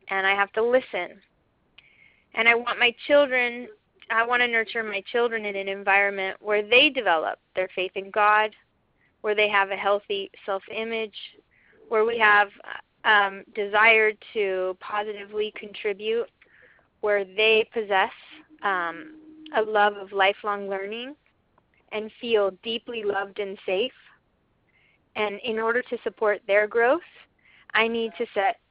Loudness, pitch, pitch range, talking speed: -24 LUFS, 215 Hz, 200-235 Hz, 140 wpm